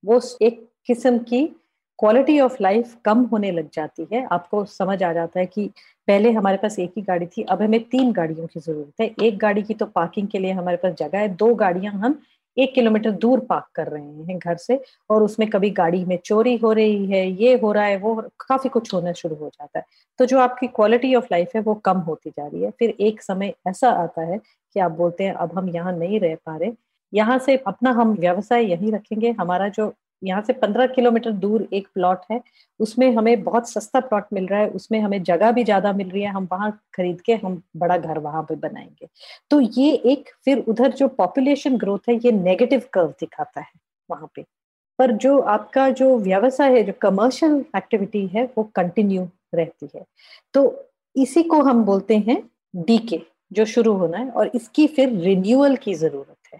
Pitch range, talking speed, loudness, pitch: 185-245 Hz, 210 wpm, -20 LUFS, 215 Hz